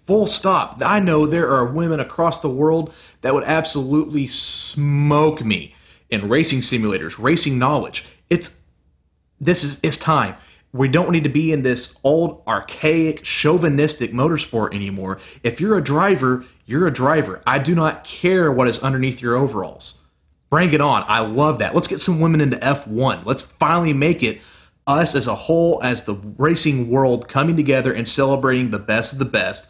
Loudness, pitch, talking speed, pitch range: -18 LUFS, 140 Hz, 175 wpm, 120-160 Hz